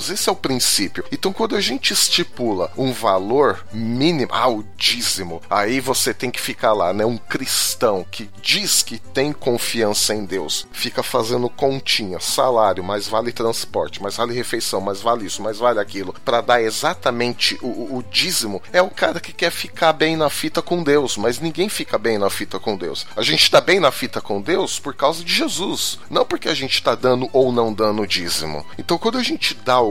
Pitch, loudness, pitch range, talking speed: 120 Hz, -19 LUFS, 105-155 Hz, 205 wpm